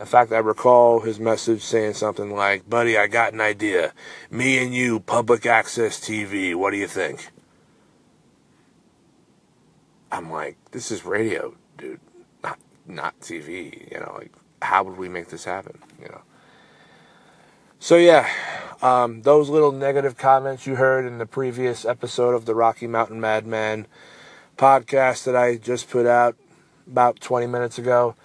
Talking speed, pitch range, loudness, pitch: 155 wpm, 110-125 Hz, -20 LUFS, 120 Hz